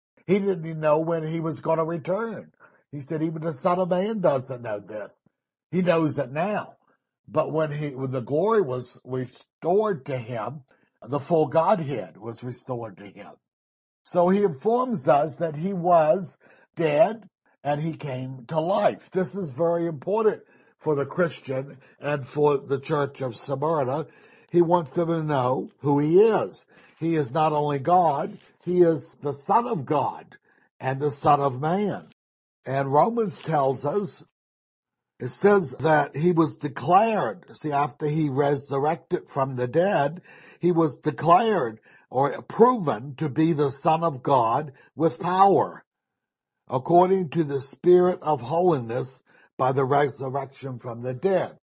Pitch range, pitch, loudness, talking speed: 135-175 Hz, 155 Hz, -24 LUFS, 155 wpm